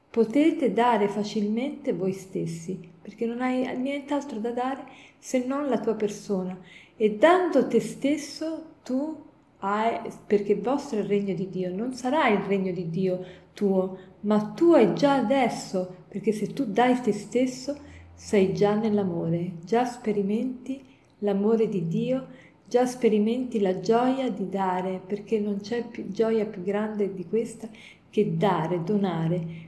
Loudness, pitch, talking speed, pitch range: -26 LUFS, 215 Hz, 150 wpm, 190-250 Hz